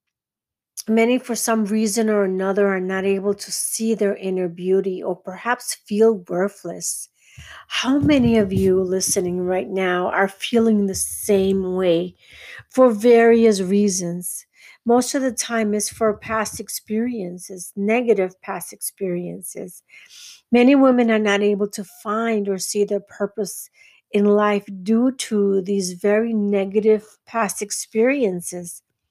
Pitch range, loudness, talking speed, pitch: 190-225 Hz, -20 LUFS, 130 wpm, 205 Hz